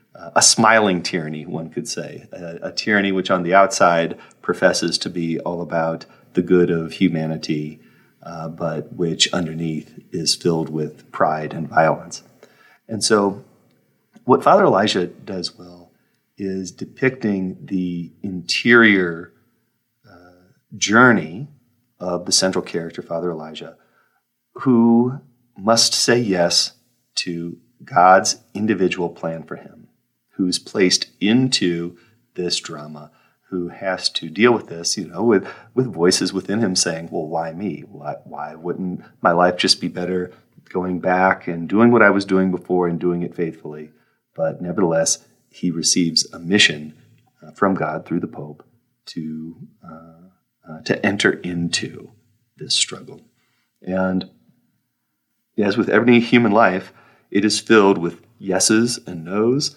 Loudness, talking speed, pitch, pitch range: -18 LUFS, 140 wpm, 90 Hz, 85-105 Hz